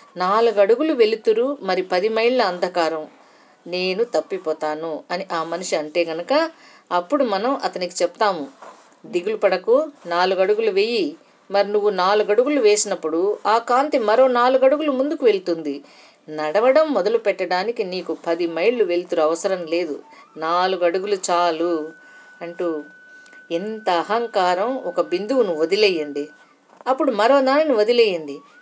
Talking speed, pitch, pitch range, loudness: 115 wpm, 200 Hz, 175-285 Hz, -20 LUFS